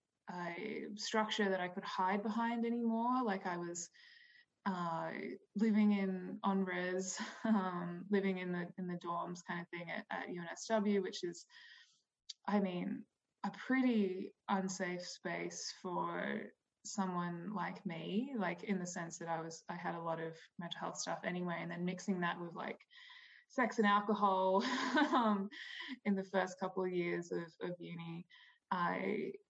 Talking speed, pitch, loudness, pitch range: 155 wpm, 195 Hz, -39 LUFS, 175-220 Hz